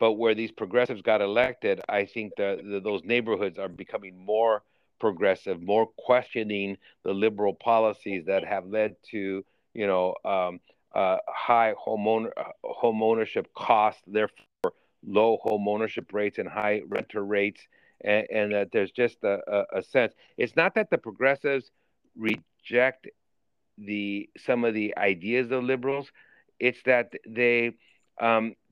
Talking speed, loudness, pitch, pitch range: 145 wpm, -27 LUFS, 110 Hz, 100-120 Hz